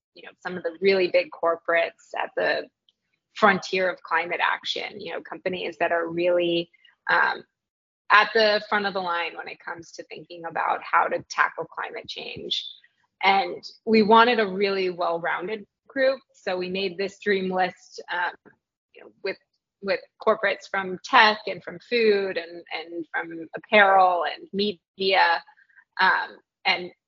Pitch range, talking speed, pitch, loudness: 170-210 Hz, 155 wpm, 190 Hz, -23 LUFS